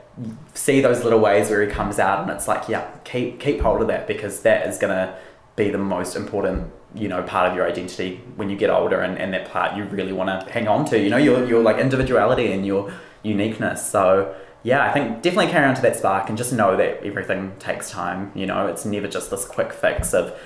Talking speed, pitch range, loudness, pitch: 240 wpm, 95-110 Hz, -21 LUFS, 100 Hz